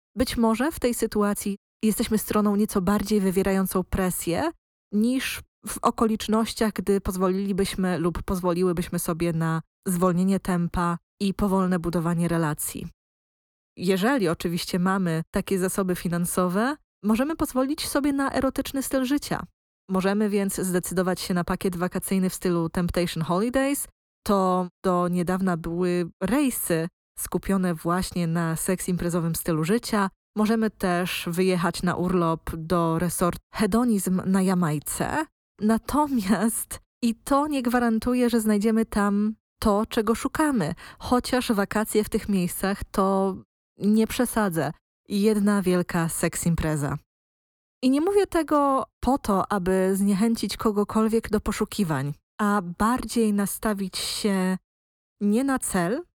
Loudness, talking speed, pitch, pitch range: -25 LUFS, 120 wpm, 195 Hz, 180-225 Hz